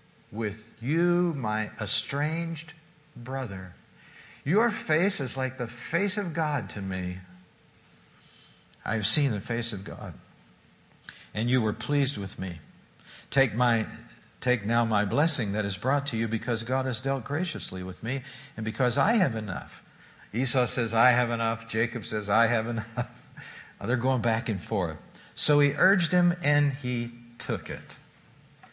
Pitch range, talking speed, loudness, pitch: 110-145 Hz, 155 wpm, -27 LUFS, 120 Hz